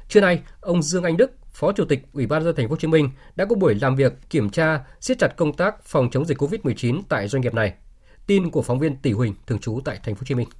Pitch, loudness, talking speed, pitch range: 140 Hz, -22 LUFS, 285 wpm, 125-160 Hz